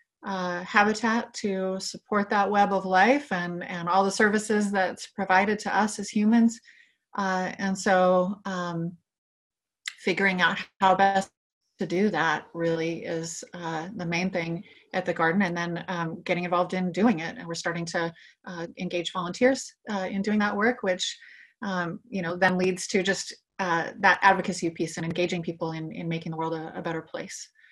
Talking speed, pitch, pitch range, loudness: 180 wpm, 185 Hz, 175-205 Hz, -26 LUFS